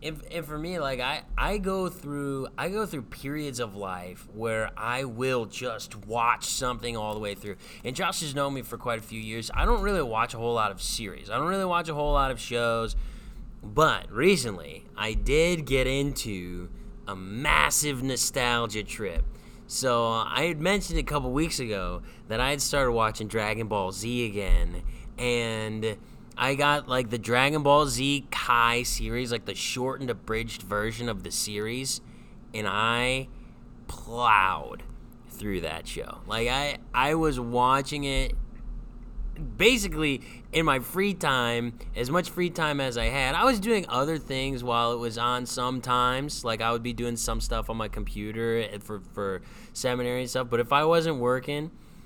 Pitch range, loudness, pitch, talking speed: 110-145 Hz, -27 LUFS, 125 Hz, 175 wpm